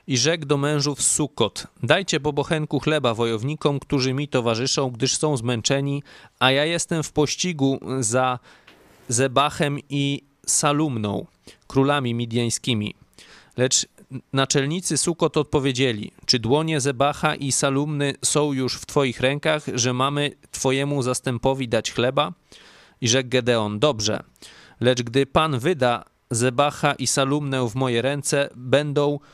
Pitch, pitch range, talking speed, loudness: 135 Hz, 125-145 Hz, 125 wpm, -22 LUFS